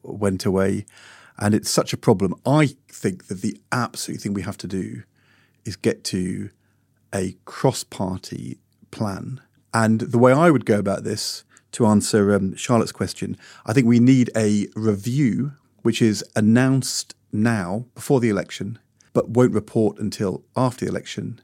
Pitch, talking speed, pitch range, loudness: 115 Hz, 160 wpm, 105-125 Hz, -21 LUFS